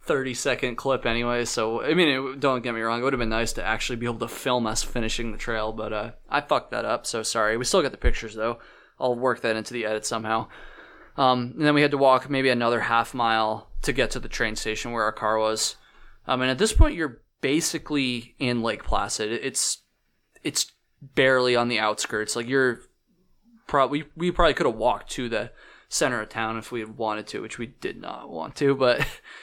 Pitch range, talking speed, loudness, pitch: 110-130 Hz, 220 wpm, -25 LUFS, 120 Hz